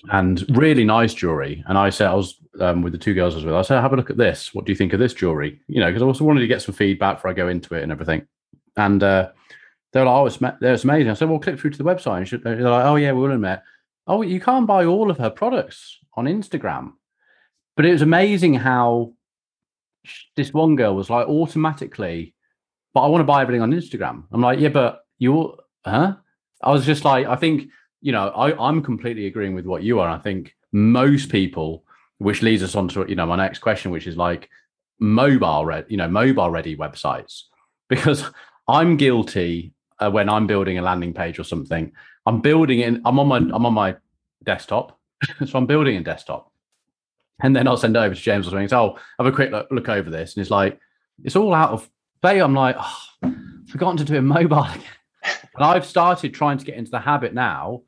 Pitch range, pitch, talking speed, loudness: 95-140 Hz, 120 Hz, 230 wpm, -19 LUFS